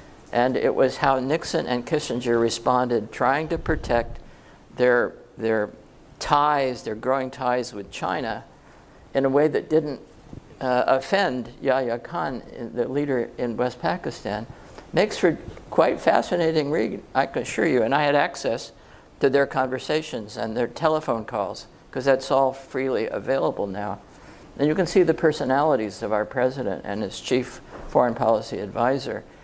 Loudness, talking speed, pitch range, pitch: -24 LUFS, 150 wpm, 120-145 Hz, 130 Hz